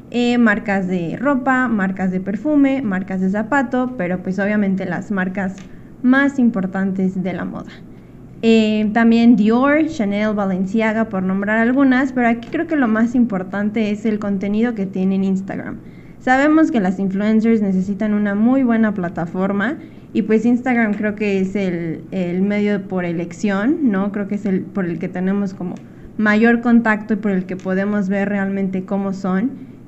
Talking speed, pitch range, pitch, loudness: 165 wpm, 190-230 Hz, 205 Hz, -18 LUFS